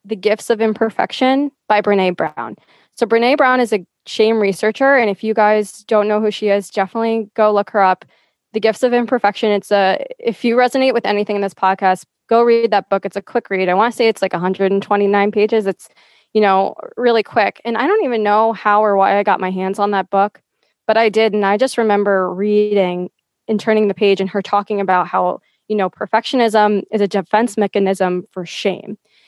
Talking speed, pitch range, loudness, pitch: 215 wpm, 195-225 Hz, -16 LUFS, 210 Hz